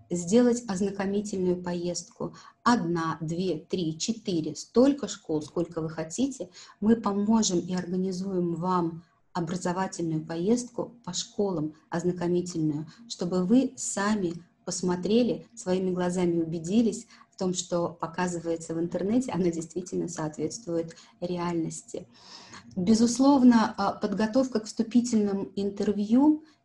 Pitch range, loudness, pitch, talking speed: 170-220 Hz, -28 LUFS, 185 Hz, 100 wpm